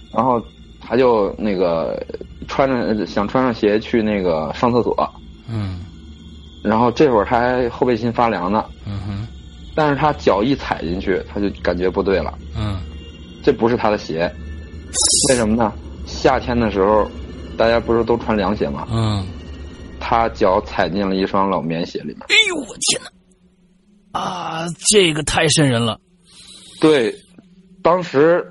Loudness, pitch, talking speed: -18 LUFS, 110 Hz, 215 characters per minute